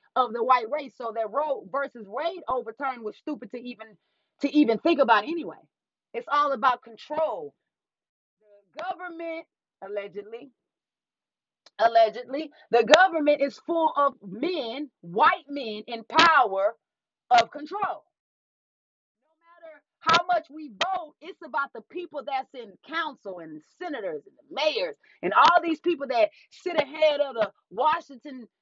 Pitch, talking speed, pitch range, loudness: 290 Hz, 140 wpm, 235-330 Hz, -25 LUFS